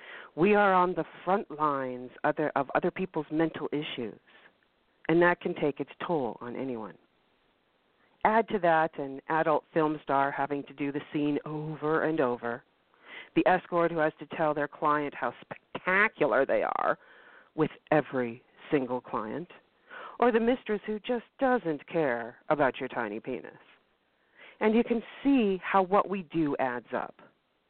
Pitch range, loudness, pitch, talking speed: 140-195 Hz, -29 LUFS, 155 Hz, 155 wpm